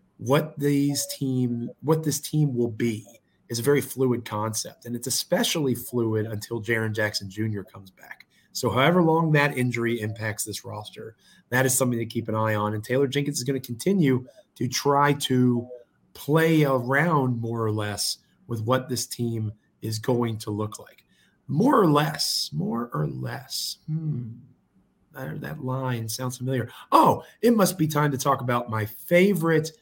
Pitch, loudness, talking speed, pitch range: 125 Hz, -25 LUFS, 170 wpm, 110-145 Hz